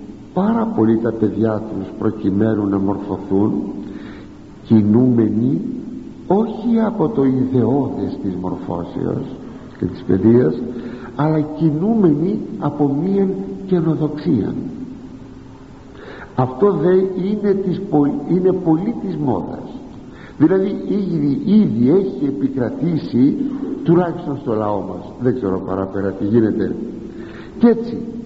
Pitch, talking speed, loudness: 145 Hz, 100 wpm, -18 LUFS